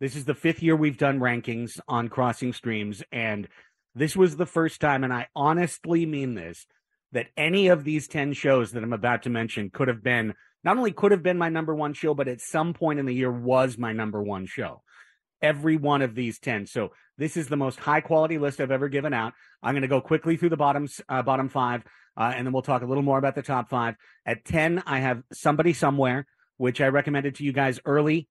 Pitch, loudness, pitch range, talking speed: 140 Hz, -25 LUFS, 125-155 Hz, 235 wpm